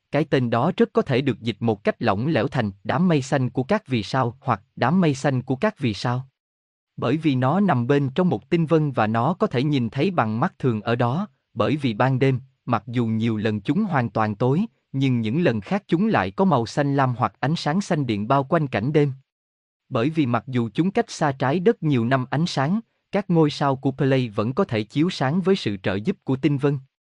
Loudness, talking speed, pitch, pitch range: -22 LUFS, 240 wpm, 135 Hz, 120-160 Hz